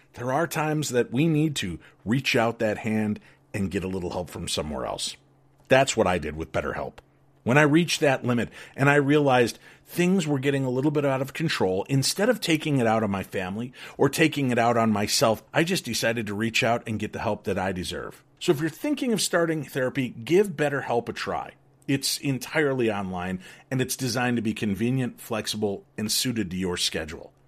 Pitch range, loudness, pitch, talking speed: 110-145 Hz, -25 LUFS, 125 Hz, 205 wpm